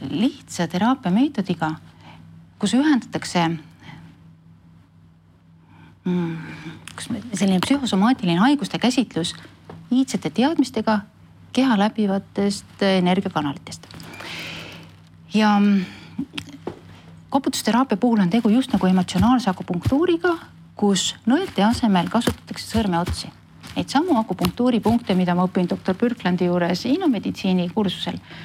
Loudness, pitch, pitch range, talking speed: -21 LUFS, 195 Hz, 170-240 Hz, 95 wpm